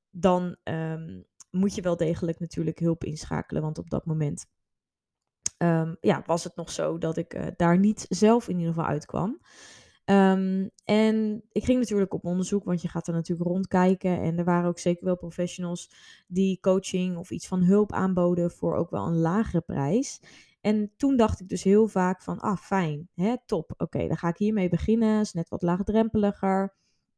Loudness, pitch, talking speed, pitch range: -26 LUFS, 180 Hz, 190 wpm, 170-200 Hz